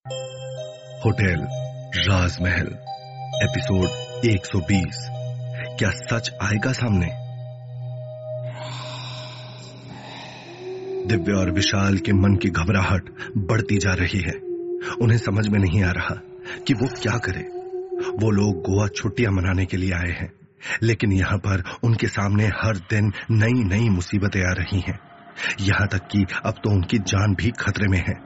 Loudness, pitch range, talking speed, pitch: -23 LUFS, 100-125 Hz, 135 wpm, 110 Hz